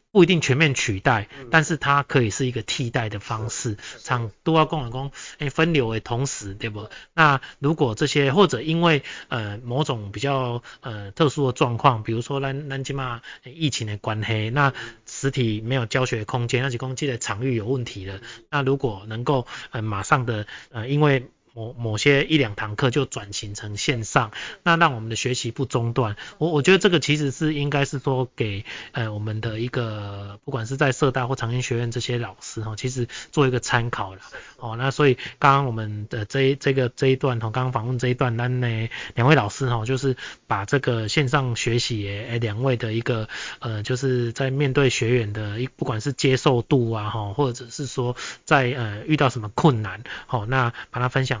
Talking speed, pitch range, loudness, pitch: 290 characters per minute, 115-140 Hz, -23 LUFS, 125 Hz